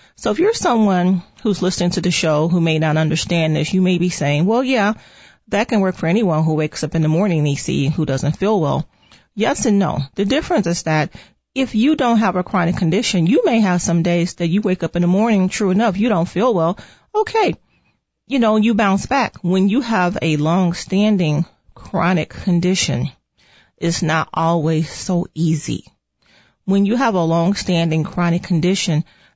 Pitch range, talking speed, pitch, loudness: 165-210 Hz, 190 wpm, 180 Hz, -17 LUFS